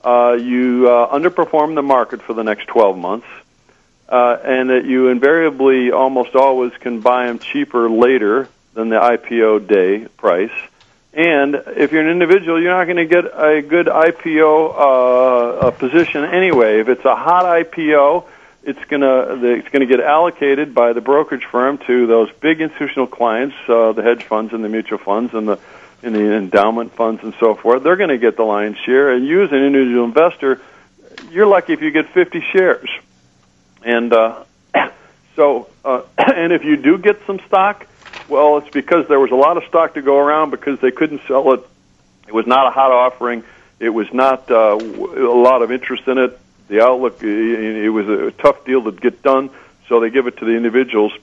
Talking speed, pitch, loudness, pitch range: 195 wpm, 130 Hz, -14 LUFS, 115-150 Hz